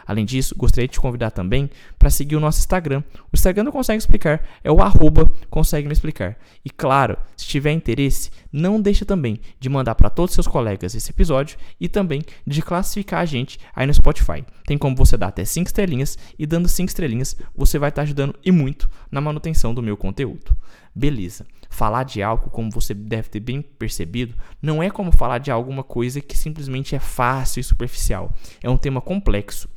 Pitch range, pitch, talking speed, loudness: 115-155 Hz, 135 Hz, 200 wpm, -21 LUFS